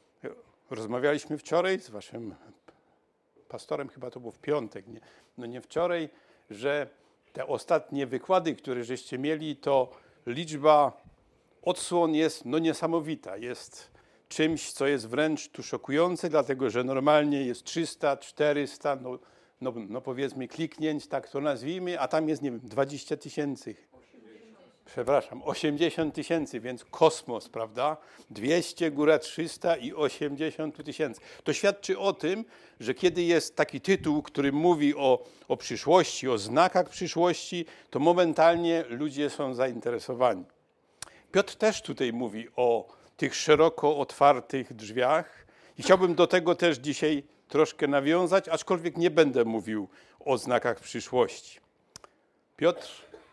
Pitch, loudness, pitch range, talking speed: 150 Hz, -28 LUFS, 130-165 Hz, 130 wpm